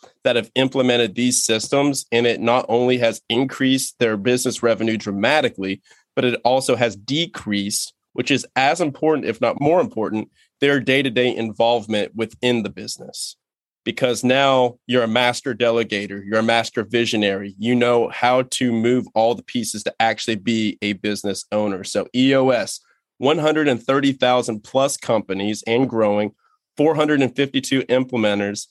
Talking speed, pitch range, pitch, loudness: 145 wpm, 110-130 Hz, 120 Hz, -19 LUFS